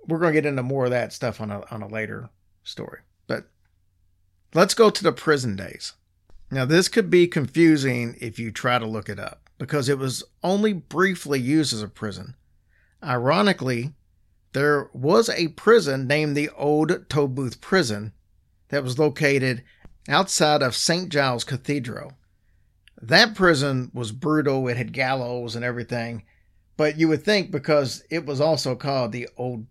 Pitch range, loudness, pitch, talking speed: 110-155 Hz, -22 LUFS, 130 Hz, 165 wpm